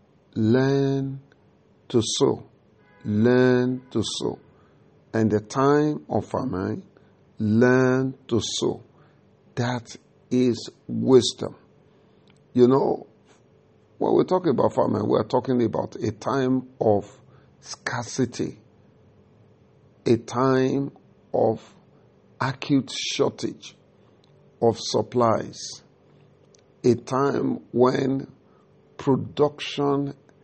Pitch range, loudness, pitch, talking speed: 115-135 Hz, -24 LUFS, 125 Hz, 85 wpm